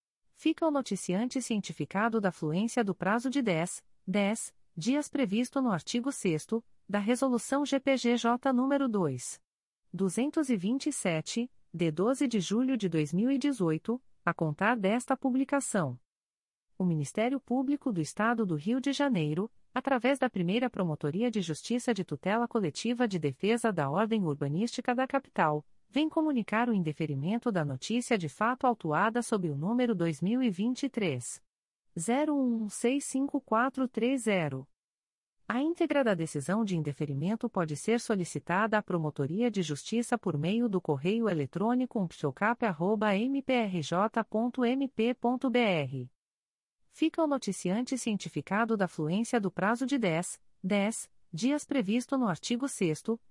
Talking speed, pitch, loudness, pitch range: 120 wpm, 225 Hz, -31 LUFS, 180-250 Hz